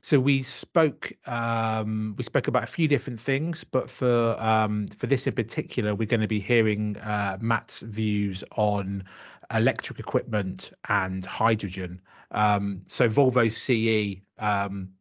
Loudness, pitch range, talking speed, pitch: -26 LUFS, 105-125 Hz, 145 wpm, 110 Hz